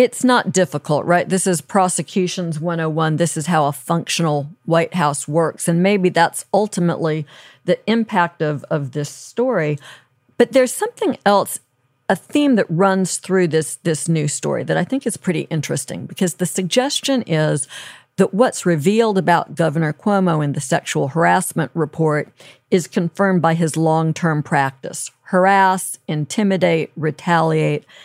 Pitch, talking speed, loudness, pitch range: 170 Hz, 150 wpm, -18 LUFS, 155-195 Hz